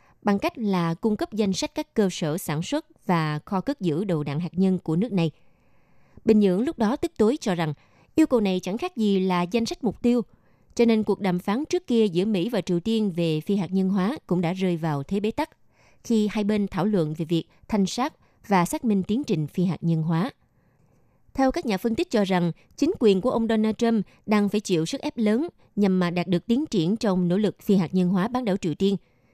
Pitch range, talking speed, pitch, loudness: 175-225 Hz, 245 wpm, 200 Hz, -24 LUFS